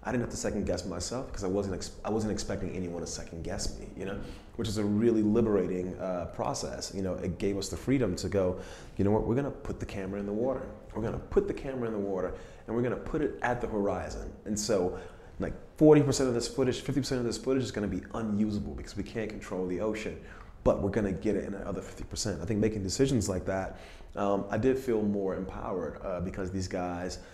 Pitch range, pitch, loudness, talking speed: 95-115 Hz, 100 Hz, -31 LUFS, 250 wpm